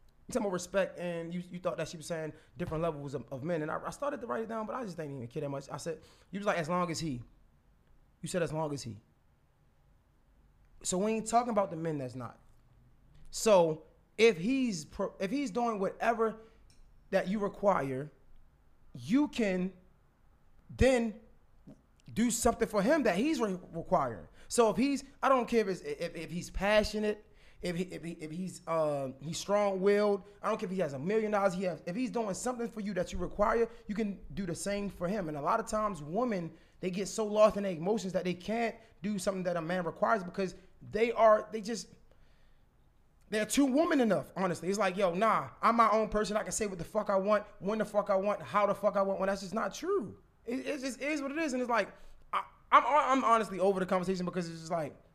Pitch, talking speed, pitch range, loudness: 195 Hz, 225 wpm, 170-220 Hz, -32 LUFS